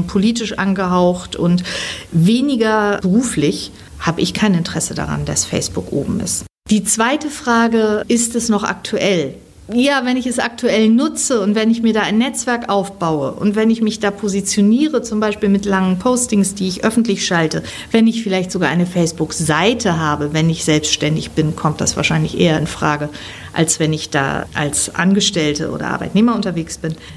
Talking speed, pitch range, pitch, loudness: 170 wpm, 170-225 Hz, 200 Hz, -16 LUFS